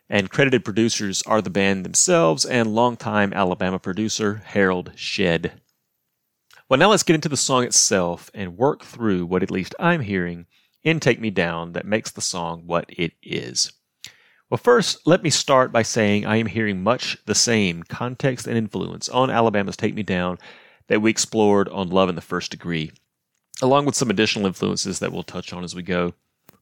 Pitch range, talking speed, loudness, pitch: 90-120 Hz, 185 wpm, -21 LUFS, 105 Hz